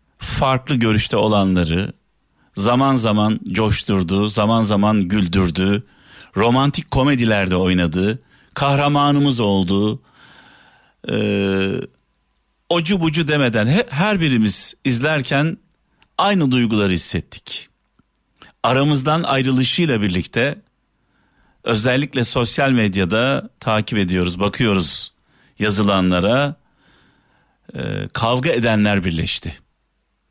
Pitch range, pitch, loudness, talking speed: 100-135 Hz, 110 Hz, -18 LUFS, 75 wpm